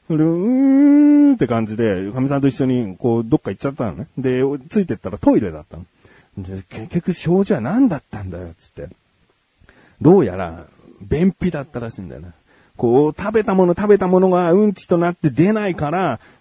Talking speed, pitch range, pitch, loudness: 365 characters per minute, 115-190 Hz, 145 Hz, -17 LUFS